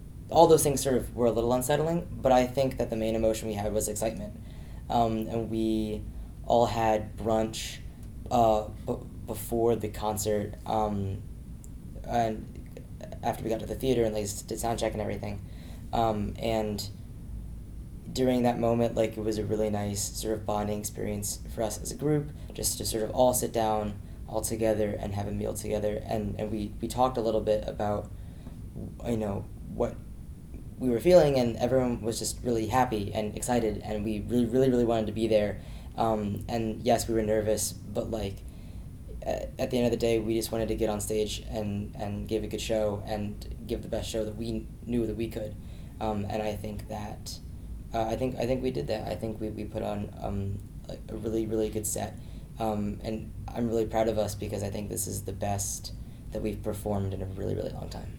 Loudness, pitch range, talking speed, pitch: -30 LUFS, 105-115 Hz, 205 wpm, 110 Hz